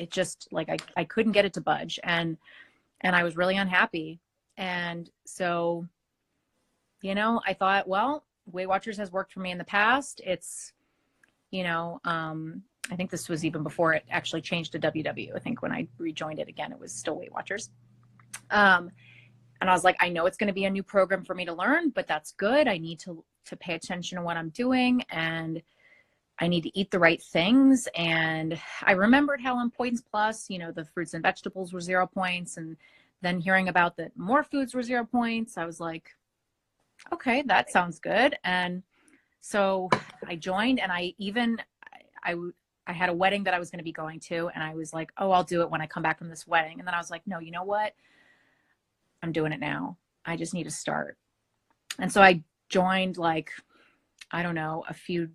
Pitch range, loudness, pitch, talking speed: 165-200 Hz, -27 LUFS, 180 Hz, 210 wpm